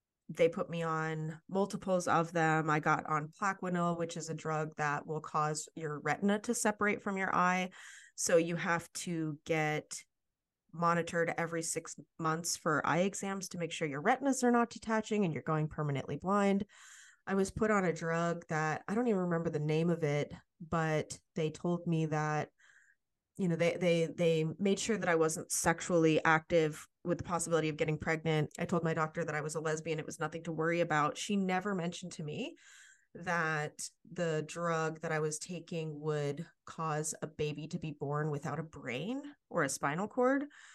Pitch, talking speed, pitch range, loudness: 165 Hz, 190 wpm, 155-185 Hz, -34 LUFS